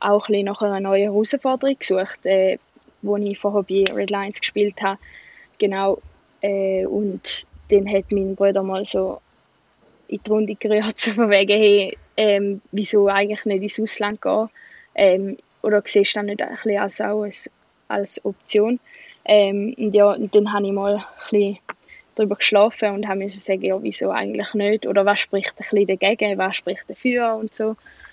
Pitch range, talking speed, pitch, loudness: 200-215 Hz, 160 wpm, 205 Hz, -20 LUFS